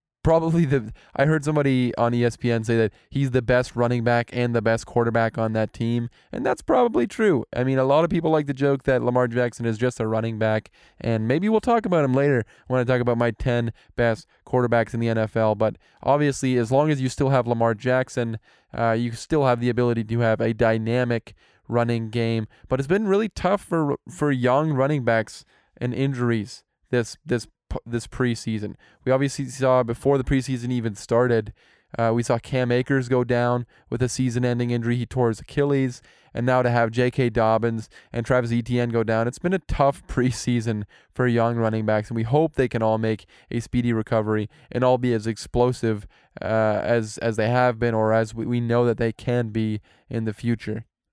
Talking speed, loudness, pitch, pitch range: 205 wpm, -23 LUFS, 120 Hz, 115-130 Hz